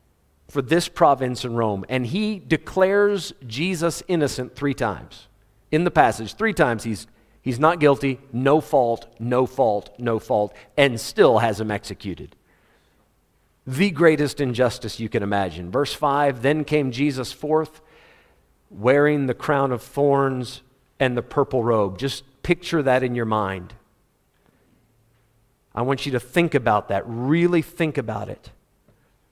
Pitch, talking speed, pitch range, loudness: 130 Hz, 145 wpm, 115-150 Hz, -22 LUFS